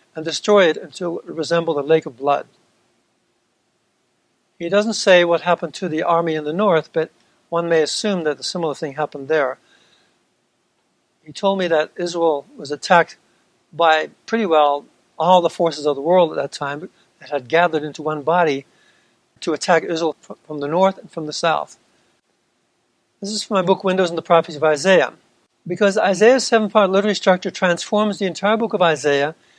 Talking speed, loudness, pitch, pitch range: 180 wpm, -18 LUFS, 170 Hz, 155-190 Hz